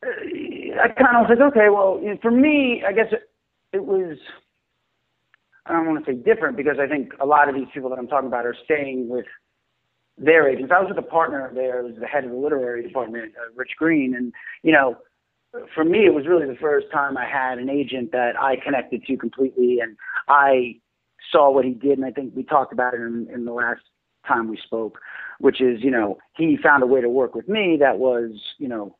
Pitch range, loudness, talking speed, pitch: 125-195 Hz, -20 LUFS, 225 wpm, 135 Hz